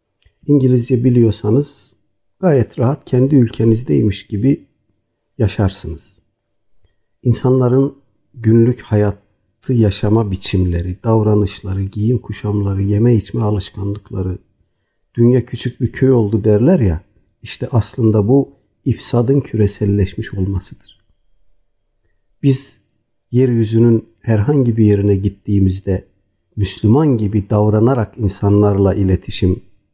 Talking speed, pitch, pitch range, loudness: 85 wpm, 105 Hz, 100-120 Hz, -15 LUFS